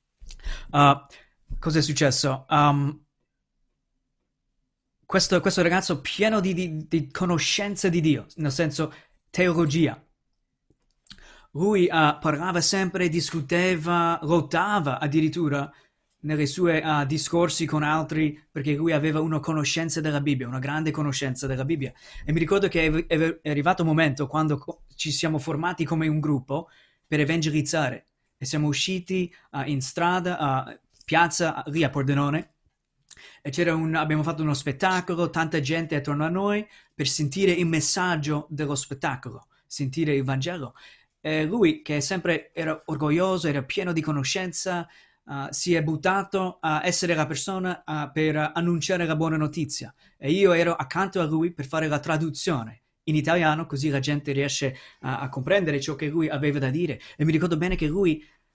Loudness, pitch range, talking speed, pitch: -25 LUFS, 145-170 Hz, 155 wpm, 155 Hz